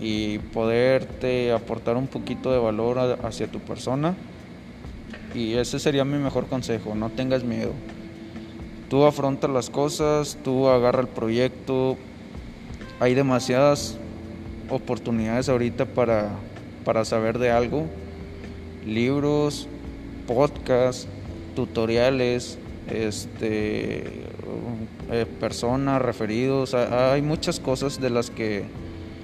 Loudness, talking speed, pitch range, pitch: -24 LUFS, 100 wpm, 110-130 Hz, 120 Hz